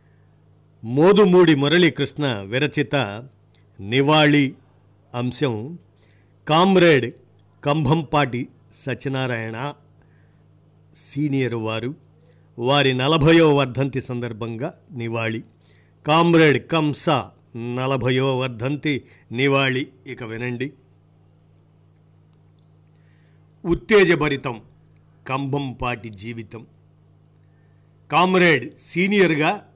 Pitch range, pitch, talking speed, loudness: 110-150 Hz, 130 Hz, 55 wpm, -20 LUFS